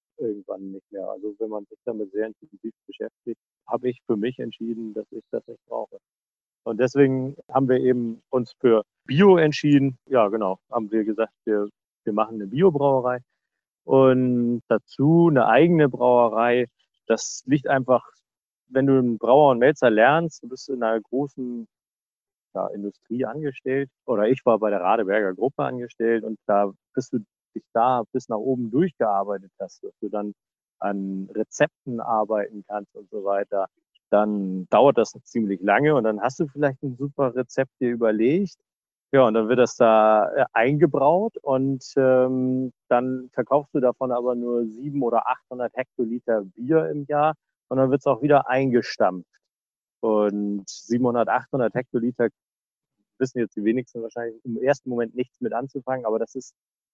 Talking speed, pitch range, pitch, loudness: 165 wpm, 110-135 Hz, 125 Hz, -22 LUFS